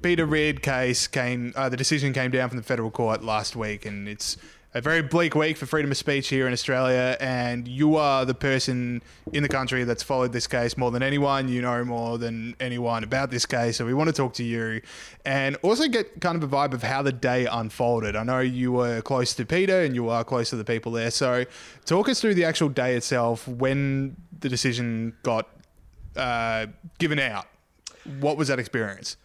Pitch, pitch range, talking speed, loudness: 130 Hz, 120-140 Hz, 215 wpm, -25 LUFS